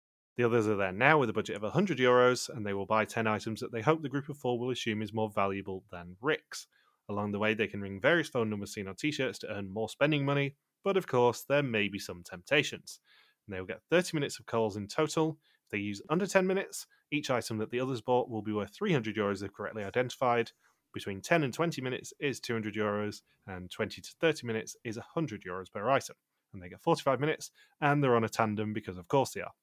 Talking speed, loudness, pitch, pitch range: 245 wpm, -32 LUFS, 115 Hz, 105-140 Hz